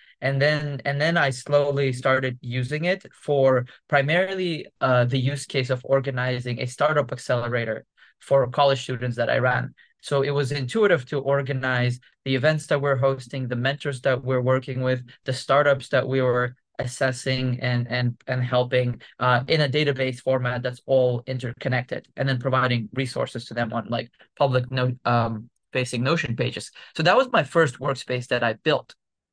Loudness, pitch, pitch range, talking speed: -24 LUFS, 130 Hz, 125-140 Hz, 170 wpm